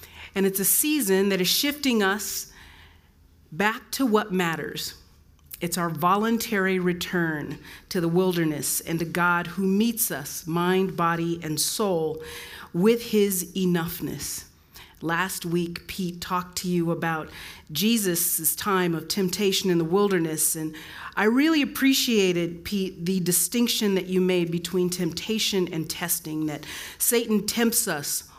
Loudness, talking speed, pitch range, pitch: -24 LUFS, 135 wpm, 165-195 Hz, 180 Hz